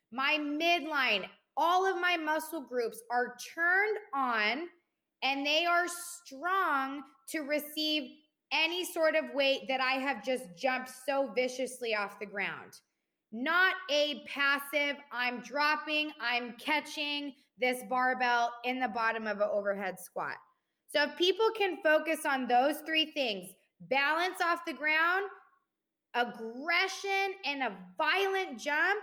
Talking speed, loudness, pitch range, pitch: 130 wpm, -31 LUFS, 250-330 Hz, 285 Hz